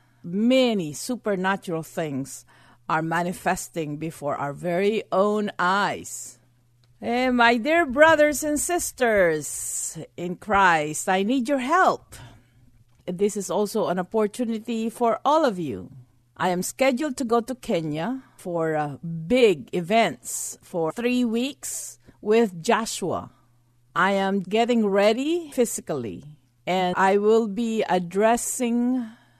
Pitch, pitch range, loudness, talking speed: 195 Hz, 155-235 Hz, -23 LUFS, 120 wpm